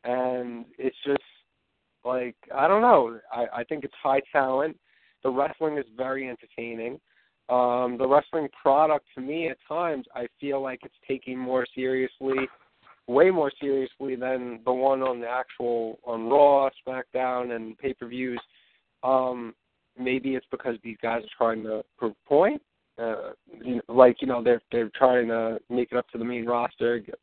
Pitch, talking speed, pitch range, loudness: 125 Hz, 170 wpm, 120-135 Hz, -26 LUFS